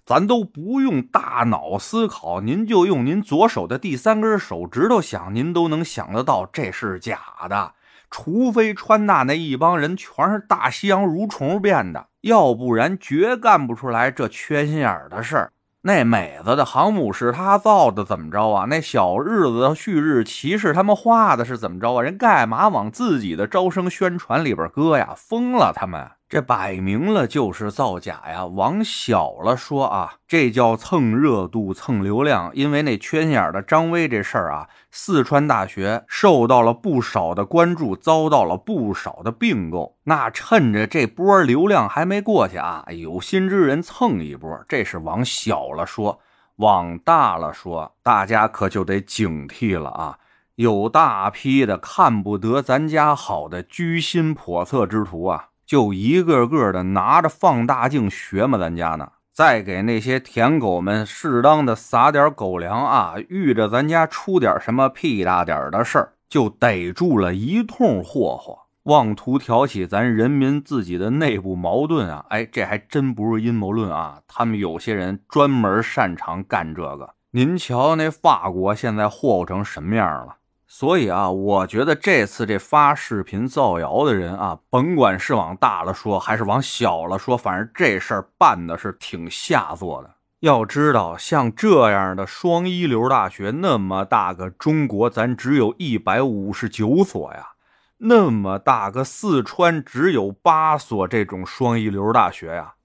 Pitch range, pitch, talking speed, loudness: 100-160 Hz, 125 Hz, 245 characters per minute, -19 LUFS